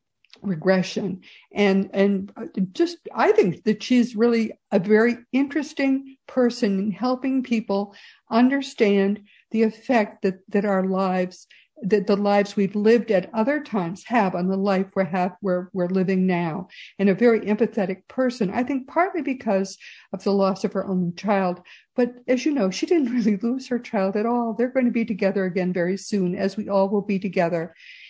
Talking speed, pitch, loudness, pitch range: 175 wpm, 205 Hz, -23 LUFS, 195-240 Hz